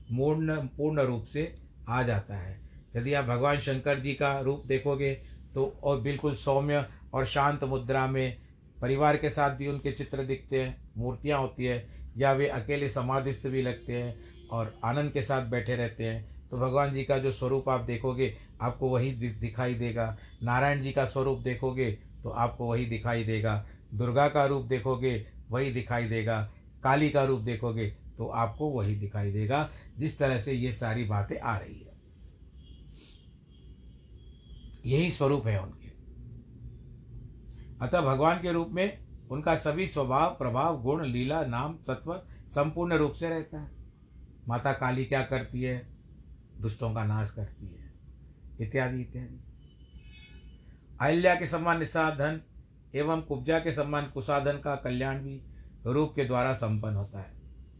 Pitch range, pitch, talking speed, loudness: 110-140 Hz, 130 Hz, 150 wpm, -30 LUFS